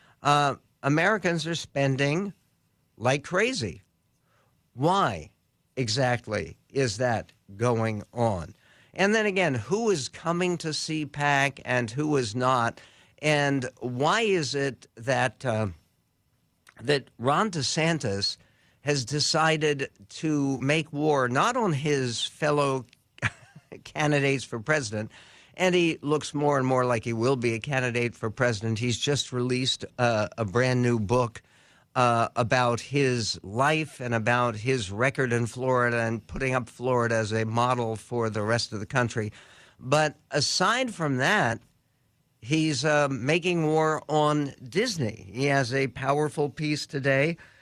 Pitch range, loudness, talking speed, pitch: 120-150 Hz, -26 LUFS, 135 wpm, 130 Hz